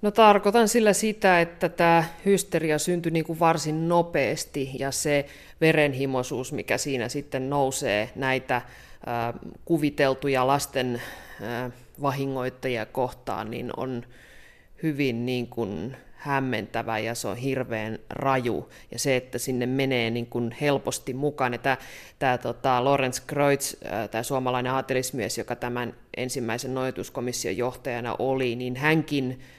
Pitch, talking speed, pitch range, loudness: 130 Hz, 130 wpm, 125-145 Hz, -26 LUFS